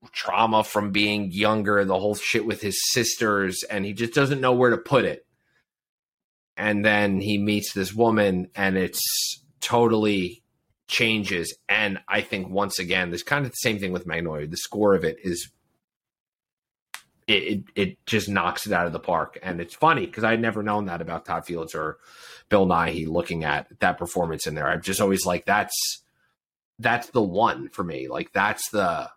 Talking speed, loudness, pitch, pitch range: 190 wpm, -24 LUFS, 105 Hz, 95-110 Hz